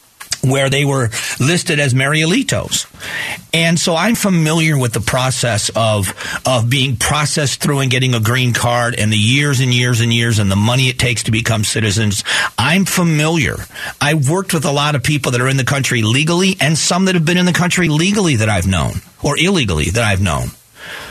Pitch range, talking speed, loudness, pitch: 115-160 Hz, 200 wpm, -14 LUFS, 130 Hz